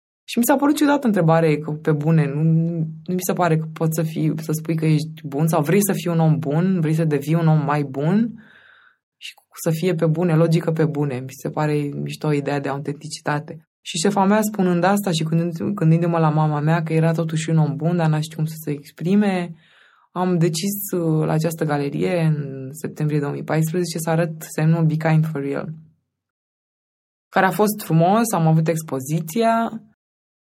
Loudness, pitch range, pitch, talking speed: -20 LUFS, 155-180 Hz, 165 Hz, 205 wpm